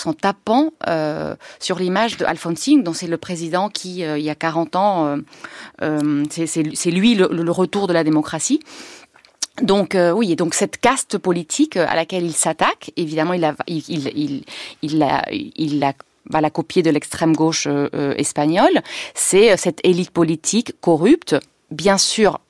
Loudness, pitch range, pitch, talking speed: -18 LUFS, 155-195 Hz, 170 Hz, 155 wpm